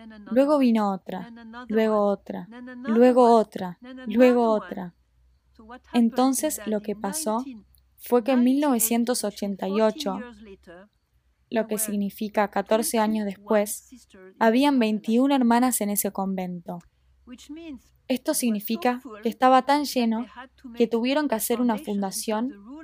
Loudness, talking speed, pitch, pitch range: -23 LUFS, 115 wpm, 225 Hz, 205-250 Hz